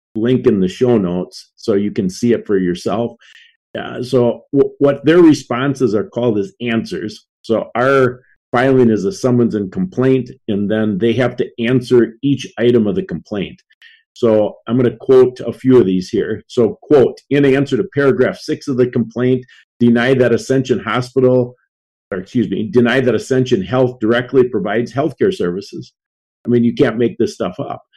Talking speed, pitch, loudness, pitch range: 180 wpm, 125 Hz, -15 LUFS, 115-135 Hz